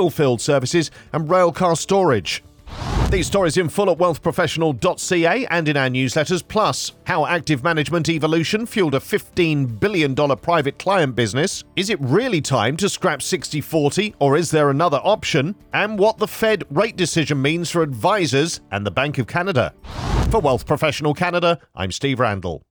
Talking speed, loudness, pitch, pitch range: 165 wpm, -19 LUFS, 160 Hz, 140-180 Hz